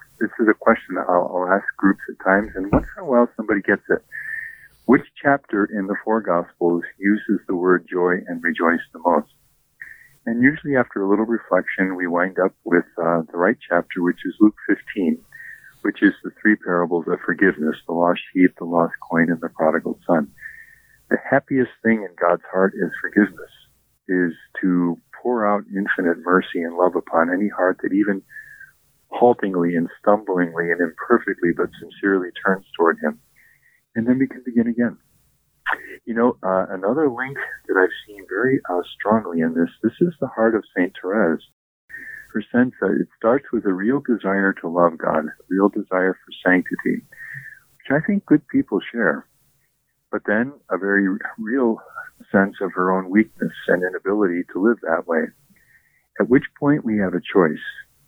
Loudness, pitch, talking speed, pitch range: -21 LUFS, 100 Hz, 175 wpm, 90-120 Hz